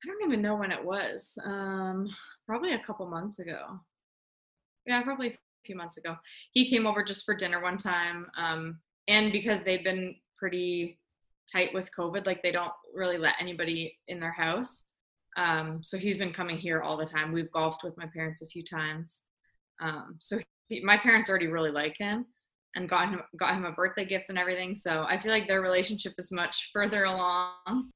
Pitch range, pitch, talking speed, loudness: 170-205 Hz, 185 Hz, 195 wpm, -30 LUFS